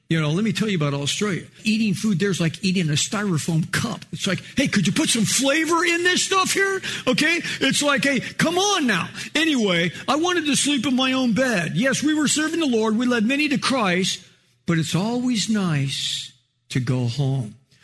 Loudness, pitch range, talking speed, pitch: -21 LUFS, 165-275 Hz, 210 wpm, 215 Hz